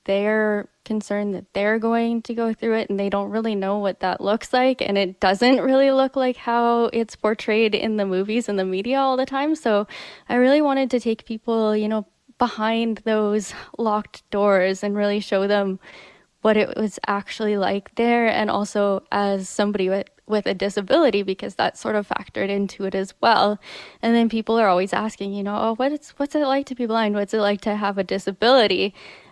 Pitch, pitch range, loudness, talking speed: 215 Hz, 200-230 Hz, -21 LUFS, 205 wpm